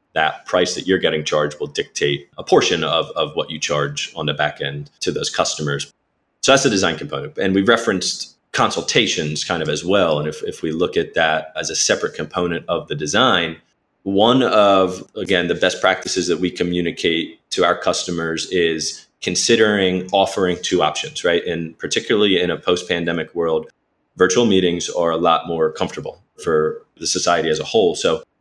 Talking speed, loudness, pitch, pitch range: 185 wpm, -18 LUFS, 90 Hz, 75-115 Hz